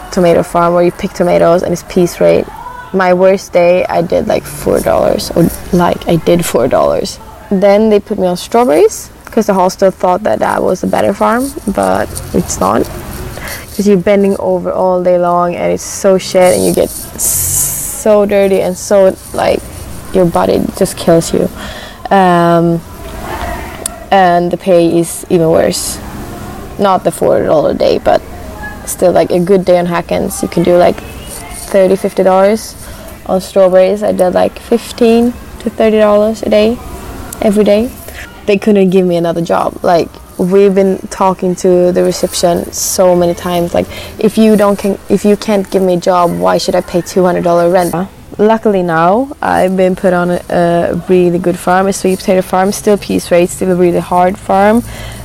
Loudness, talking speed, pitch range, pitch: -11 LUFS, 180 wpm, 175-205 Hz, 185 Hz